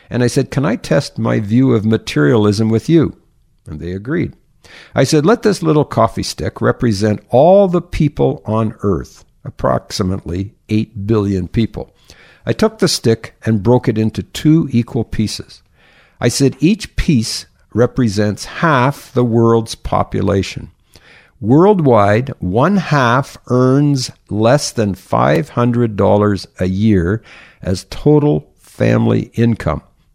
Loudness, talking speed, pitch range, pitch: -15 LUFS, 130 wpm, 100-135 Hz, 115 Hz